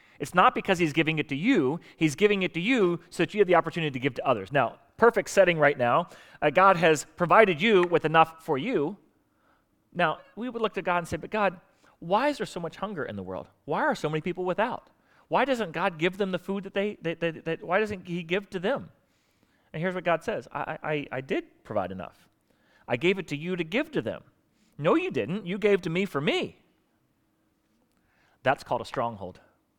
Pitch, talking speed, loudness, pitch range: 180 Hz, 230 wpm, -26 LUFS, 160-200 Hz